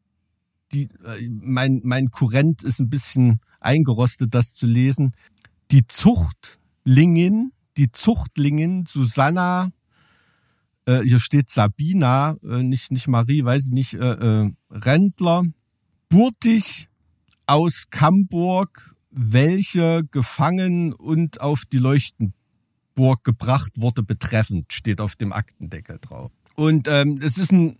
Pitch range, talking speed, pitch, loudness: 115-155 Hz, 110 wpm, 130 Hz, -19 LUFS